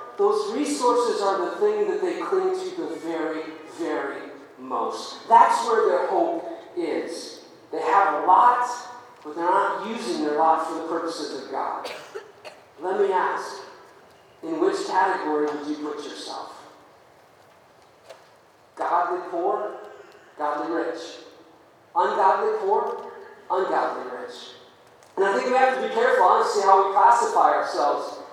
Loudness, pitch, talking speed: -23 LUFS, 245 Hz, 135 wpm